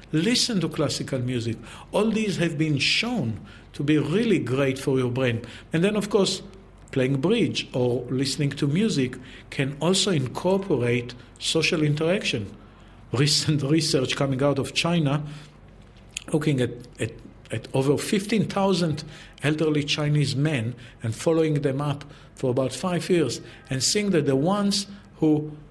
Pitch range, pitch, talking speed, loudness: 125-165 Hz, 145 Hz, 140 wpm, -24 LUFS